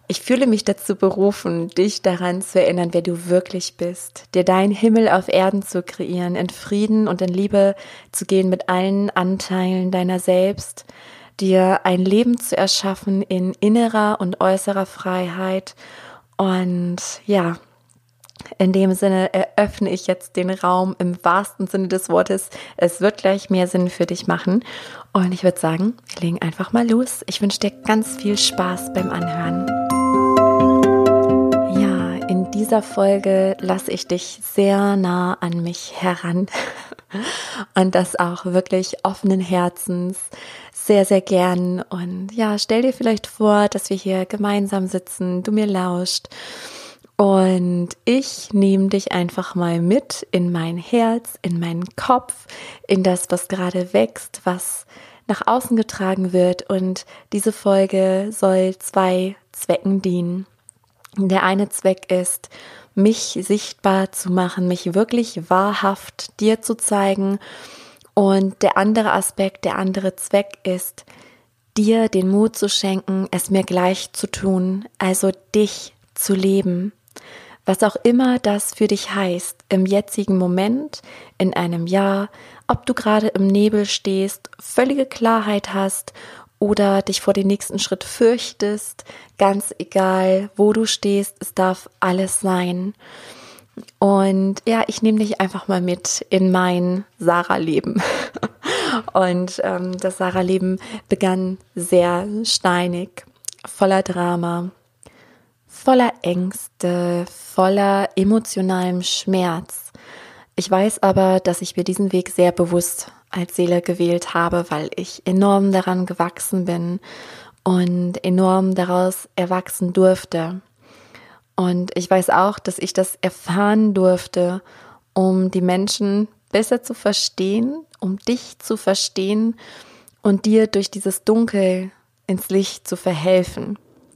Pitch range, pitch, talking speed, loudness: 180-205 Hz, 190 Hz, 135 wpm, -19 LUFS